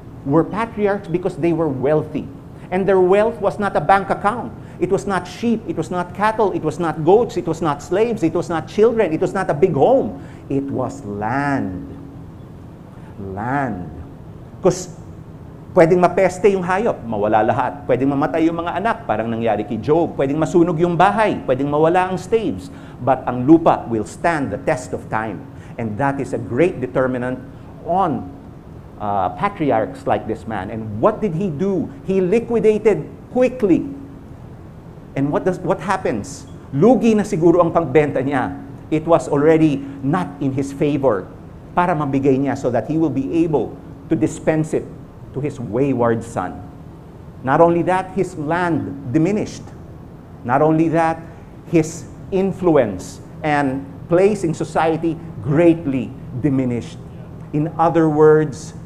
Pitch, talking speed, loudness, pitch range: 160 Hz, 155 wpm, -18 LUFS, 140-180 Hz